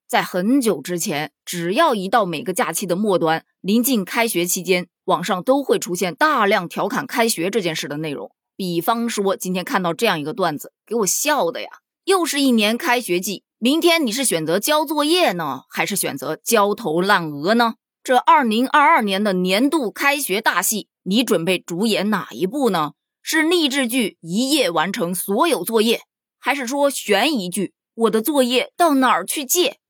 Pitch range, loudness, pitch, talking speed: 180-260 Hz, -19 LUFS, 215 Hz, 265 characters per minute